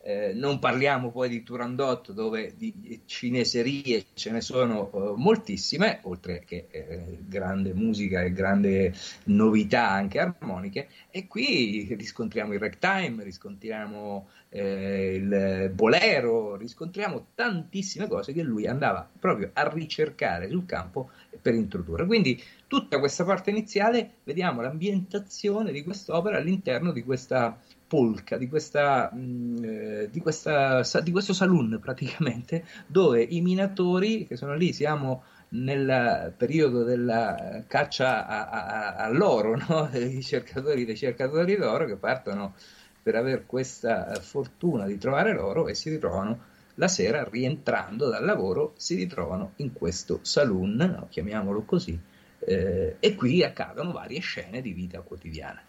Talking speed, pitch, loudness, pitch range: 130 wpm, 130 Hz, -27 LUFS, 110-180 Hz